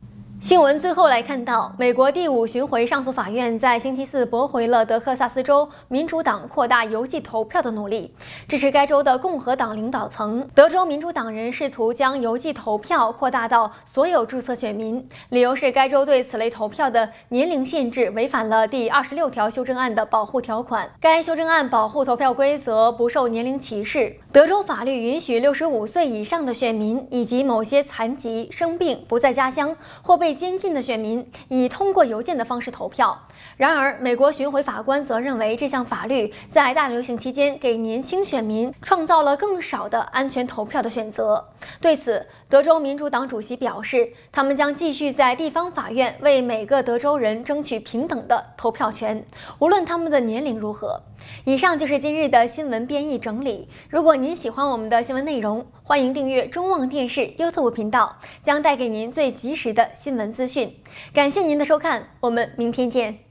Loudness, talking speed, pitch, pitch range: -21 LUFS, 295 characters per minute, 260 Hz, 235-285 Hz